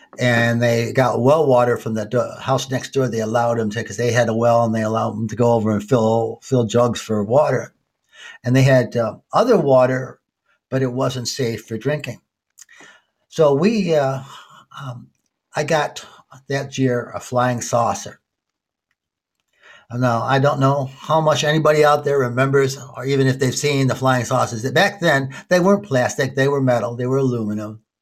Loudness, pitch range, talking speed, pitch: -18 LUFS, 115-135 Hz, 180 wpm, 125 Hz